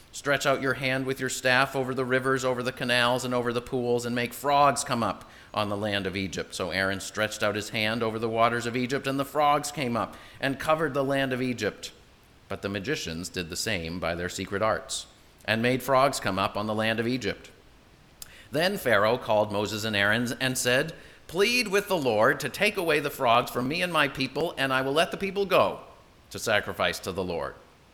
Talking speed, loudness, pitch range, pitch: 220 wpm, -26 LUFS, 110-135 Hz, 125 Hz